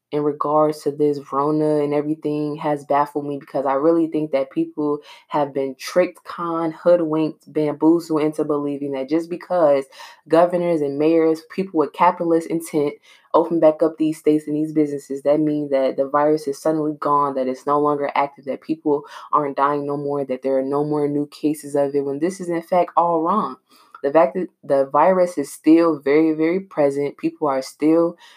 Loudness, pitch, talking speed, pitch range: -20 LUFS, 150 Hz, 190 wpm, 145-160 Hz